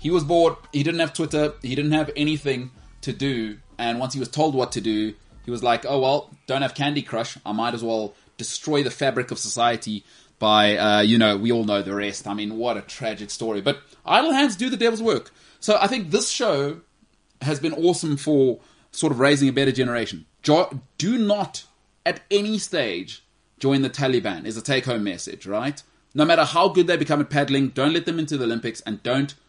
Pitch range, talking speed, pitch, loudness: 115-155 Hz, 220 wpm, 135 Hz, -22 LUFS